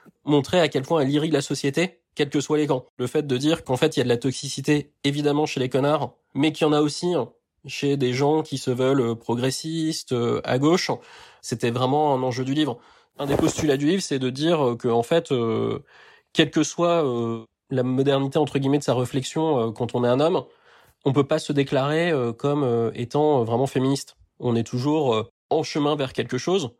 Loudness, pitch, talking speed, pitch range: -23 LUFS, 140 Hz, 225 wpm, 130-155 Hz